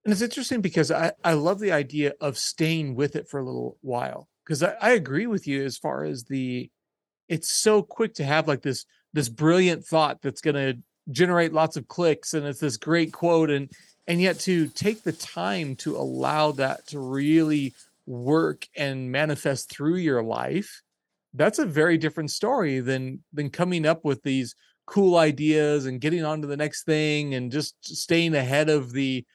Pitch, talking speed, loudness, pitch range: 150 Hz, 190 wpm, -25 LUFS, 140-165 Hz